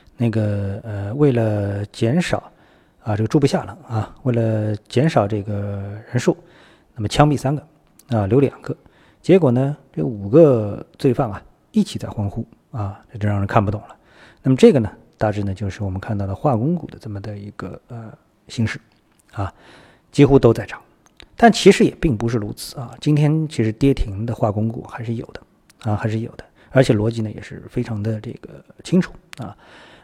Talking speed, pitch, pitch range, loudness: 265 characters per minute, 115 Hz, 105-140 Hz, -19 LUFS